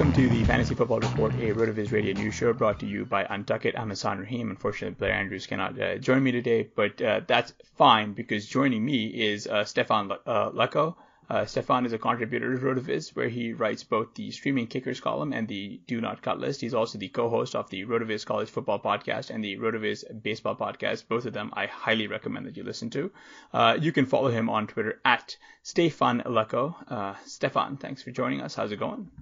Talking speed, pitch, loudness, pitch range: 215 wpm, 115 Hz, -27 LUFS, 105-125 Hz